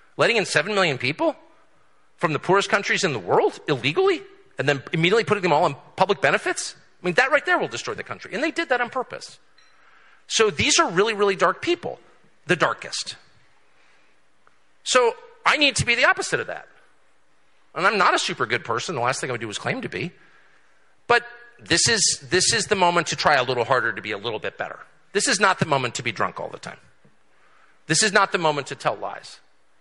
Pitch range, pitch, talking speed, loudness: 175-295 Hz, 215 Hz, 220 wpm, -21 LUFS